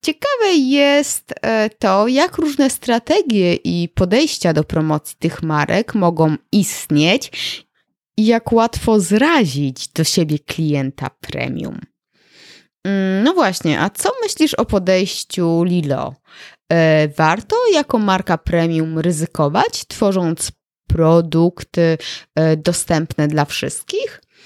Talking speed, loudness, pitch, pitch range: 100 wpm, -17 LUFS, 175 Hz, 160-230 Hz